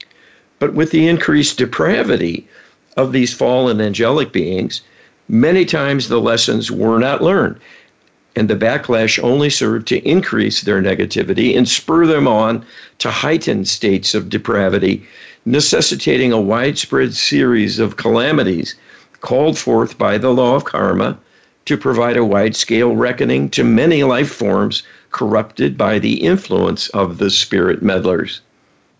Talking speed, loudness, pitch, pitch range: 135 wpm, -15 LUFS, 120 Hz, 115-140 Hz